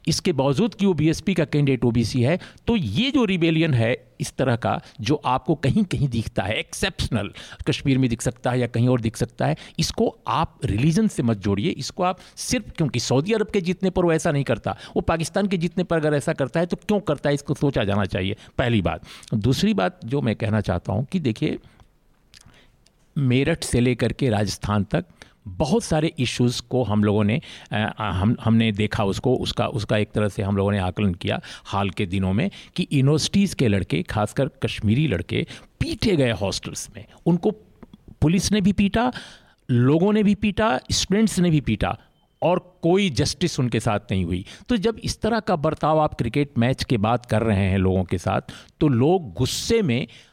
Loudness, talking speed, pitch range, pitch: -22 LUFS, 195 wpm, 110-175 Hz, 135 Hz